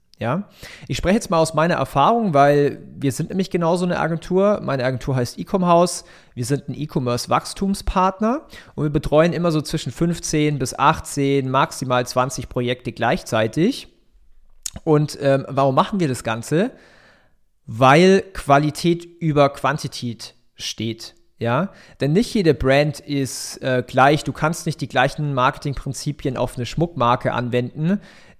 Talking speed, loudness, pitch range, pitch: 140 wpm, -20 LUFS, 130-170 Hz, 145 Hz